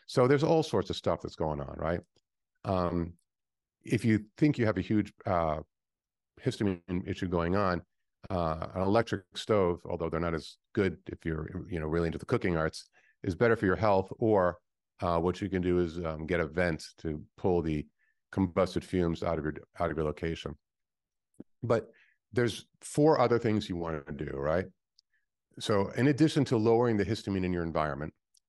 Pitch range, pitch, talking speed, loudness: 80-105 Hz, 90 Hz, 185 wpm, -31 LUFS